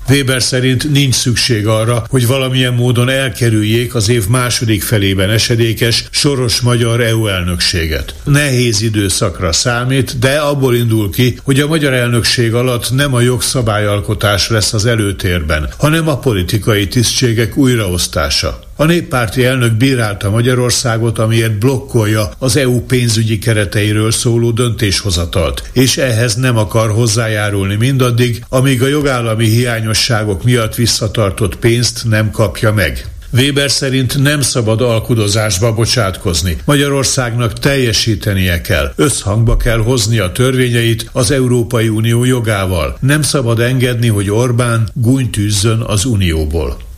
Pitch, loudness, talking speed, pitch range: 115 Hz, -12 LUFS, 125 wpm, 110-125 Hz